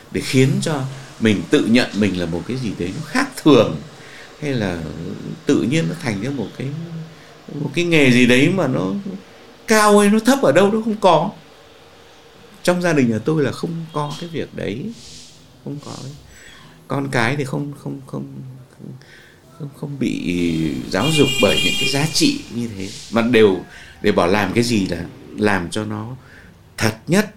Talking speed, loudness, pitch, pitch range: 185 wpm, -18 LUFS, 135 Hz, 105-155 Hz